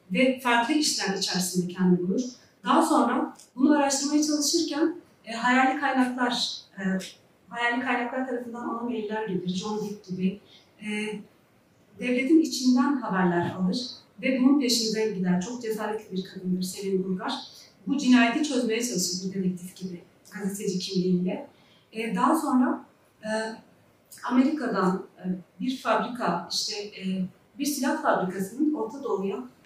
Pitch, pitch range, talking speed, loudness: 220 Hz, 190-260 Hz, 125 wpm, -26 LUFS